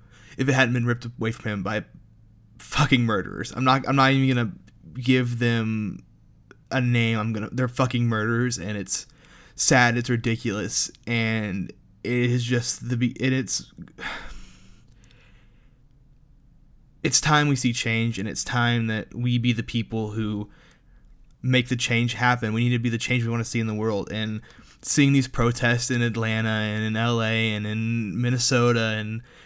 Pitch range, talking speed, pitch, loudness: 110-125 Hz, 165 wpm, 120 Hz, -24 LUFS